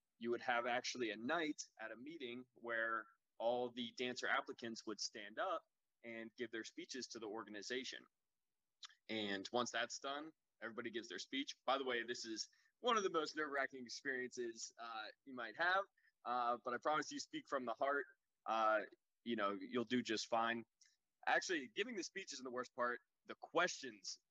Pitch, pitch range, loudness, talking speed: 120 Hz, 115-140 Hz, -43 LUFS, 180 wpm